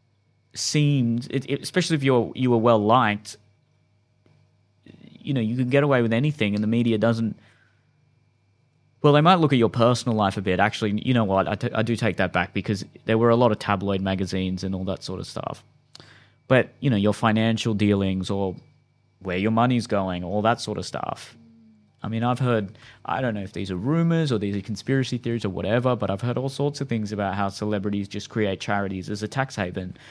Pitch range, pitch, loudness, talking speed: 100-125 Hz, 110 Hz, -23 LUFS, 215 wpm